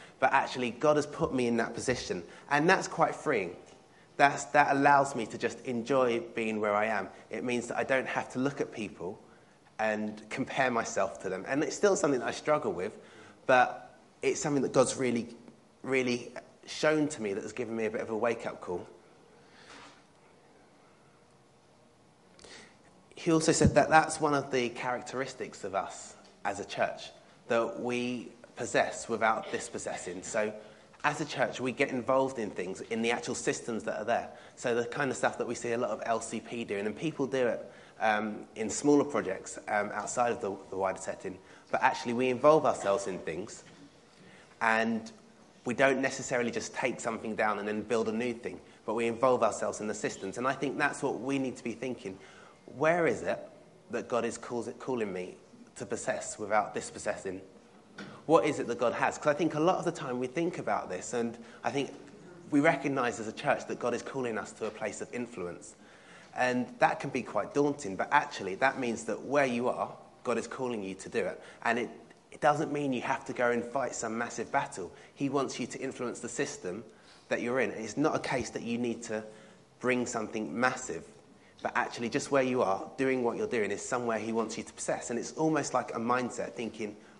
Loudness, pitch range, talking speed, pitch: -31 LUFS, 115-140 Hz, 205 wpm, 125 Hz